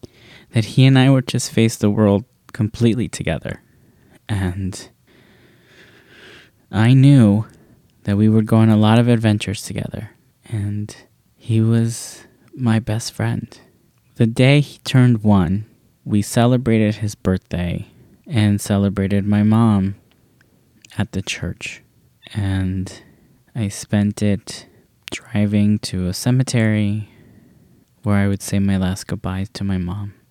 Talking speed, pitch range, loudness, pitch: 125 wpm, 100-115 Hz, -18 LUFS, 105 Hz